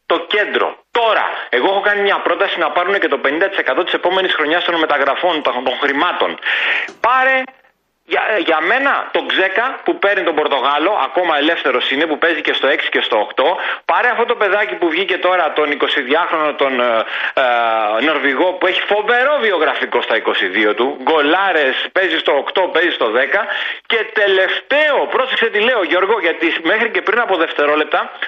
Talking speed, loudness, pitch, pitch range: 170 wpm, -15 LUFS, 195 Hz, 160-265 Hz